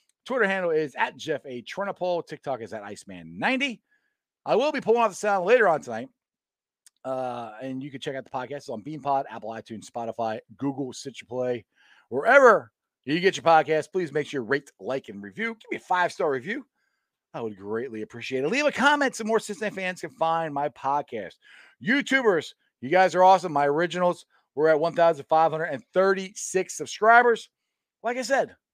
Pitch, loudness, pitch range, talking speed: 160 Hz, -25 LUFS, 130-210 Hz, 190 wpm